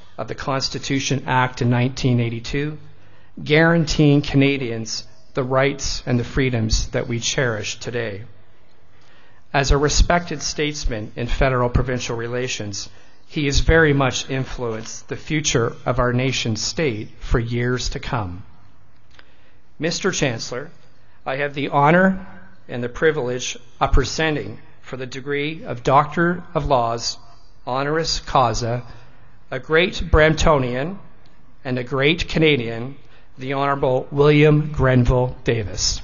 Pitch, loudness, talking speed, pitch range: 130 Hz, -20 LUFS, 120 wpm, 115-145 Hz